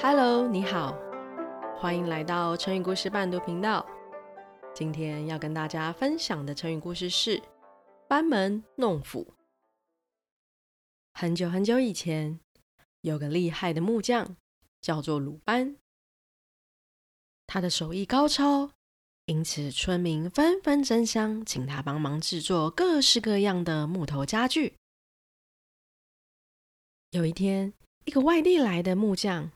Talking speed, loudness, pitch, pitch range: 190 characters per minute, -28 LUFS, 175 Hz, 155-220 Hz